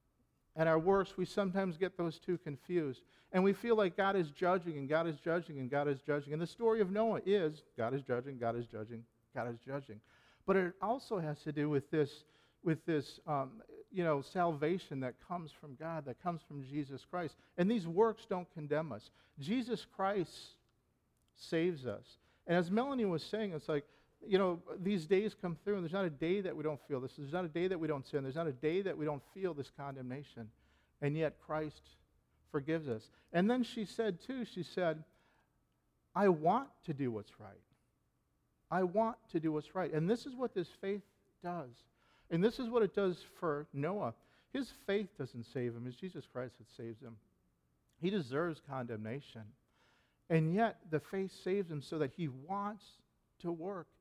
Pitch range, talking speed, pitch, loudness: 140-190 Hz, 200 wpm, 160 Hz, -38 LUFS